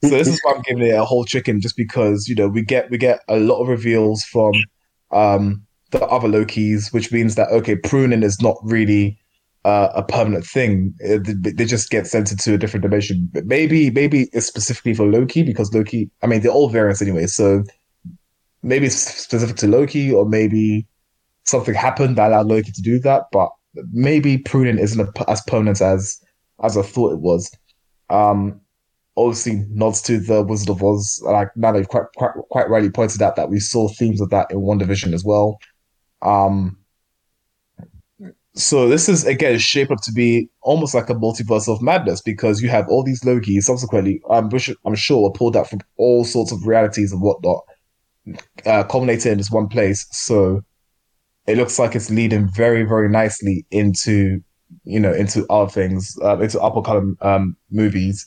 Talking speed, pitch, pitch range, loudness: 185 wpm, 110 Hz, 100-120 Hz, -17 LUFS